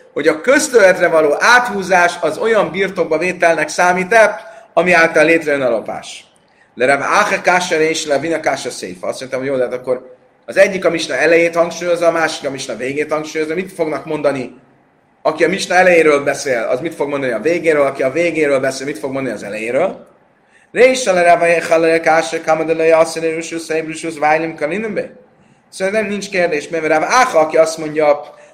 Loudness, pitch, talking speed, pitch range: -14 LUFS, 165 Hz, 150 wpm, 150-175 Hz